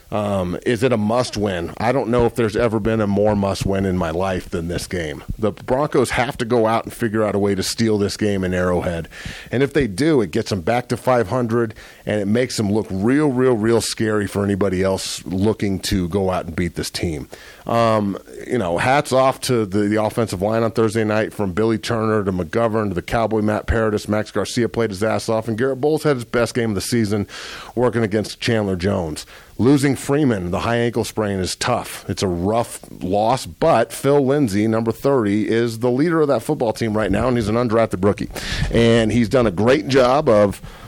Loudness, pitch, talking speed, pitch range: -19 LUFS, 110 Hz, 220 wpm, 100-120 Hz